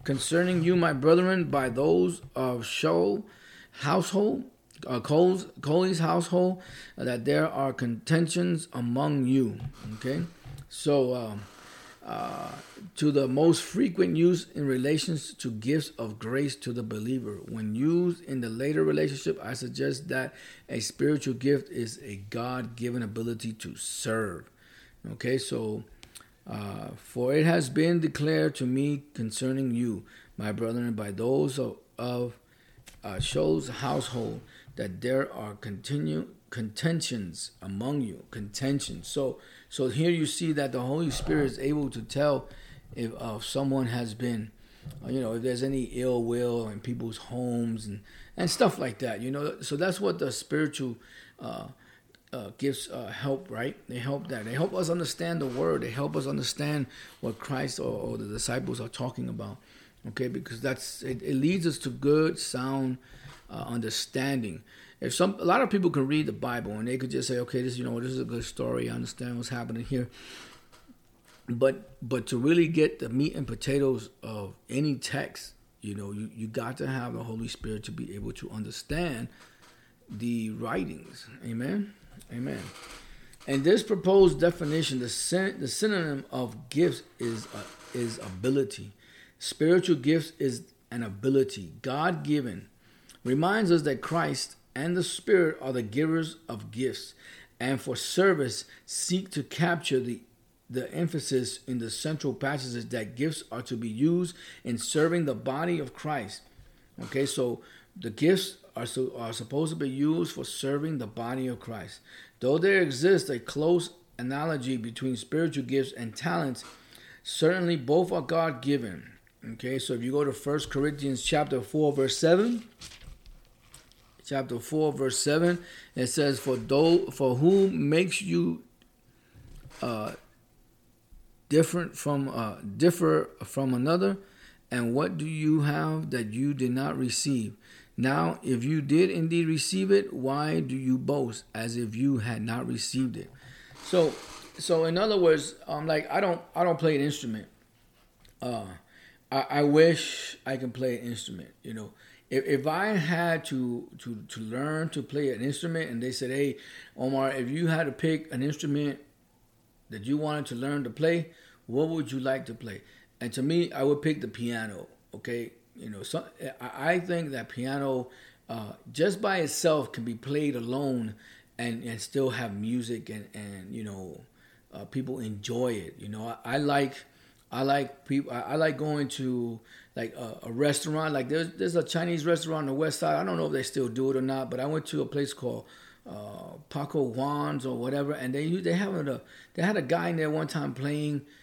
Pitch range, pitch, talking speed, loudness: 120-155 Hz, 135 Hz, 170 wpm, -29 LUFS